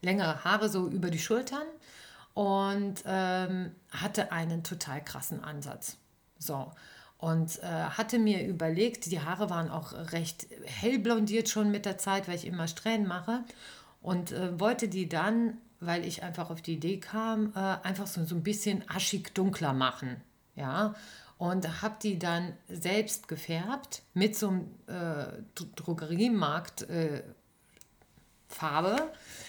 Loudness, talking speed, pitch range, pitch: -33 LUFS, 140 wpm, 165-210 Hz, 185 Hz